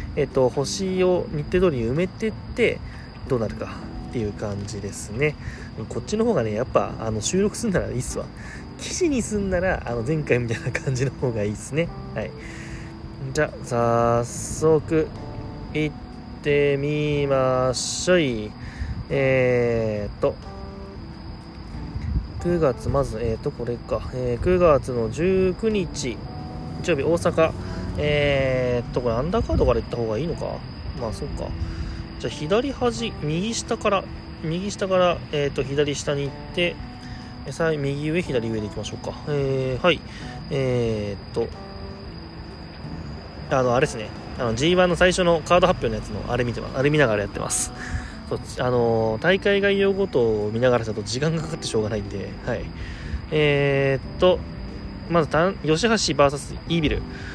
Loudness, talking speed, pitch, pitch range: -23 LUFS, 290 characters per minute, 130 Hz, 110-160 Hz